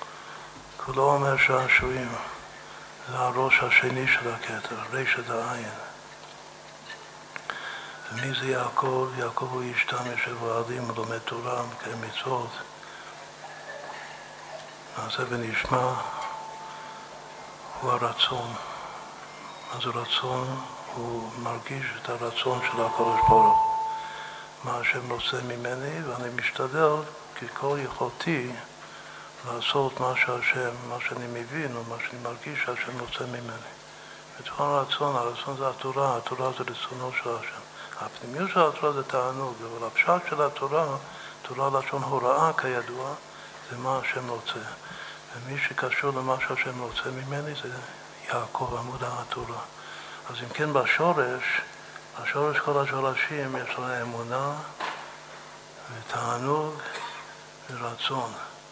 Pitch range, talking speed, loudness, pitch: 125-145 Hz, 110 wpm, -27 LUFS, 130 Hz